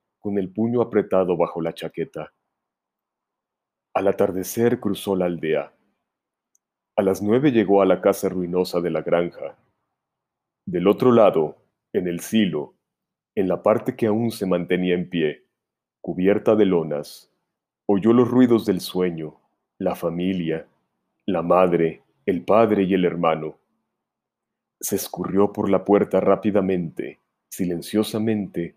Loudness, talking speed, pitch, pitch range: -21 LUFS, 130 wpm, 95 Hz, 85-105 Hz